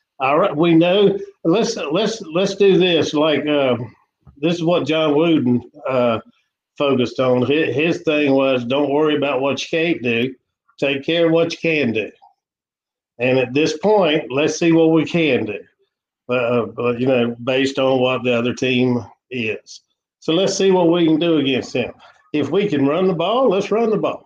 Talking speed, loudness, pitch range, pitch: 185 wpm, -18 LUFS, 130-170 Hz, 150 Hz